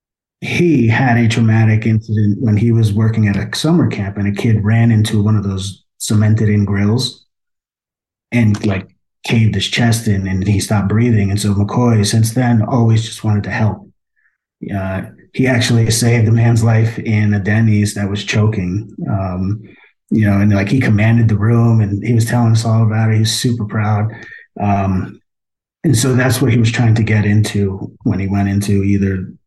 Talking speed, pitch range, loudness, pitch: 190 wpm, 100-115 Hz, -14 LUFS, 110 Hz